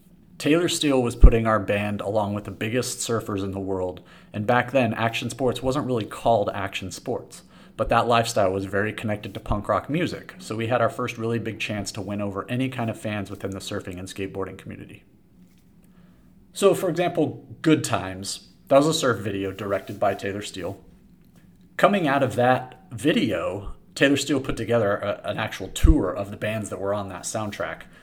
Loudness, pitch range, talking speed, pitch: -24 LUFS, 100-125 Hz, 195 wpm, 110 Hz